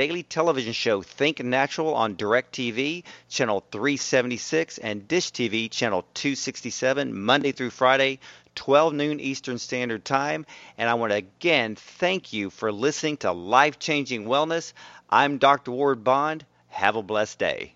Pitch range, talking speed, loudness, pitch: 115-150 Hz, 140 wpm, -24 LUFS, 135 Hz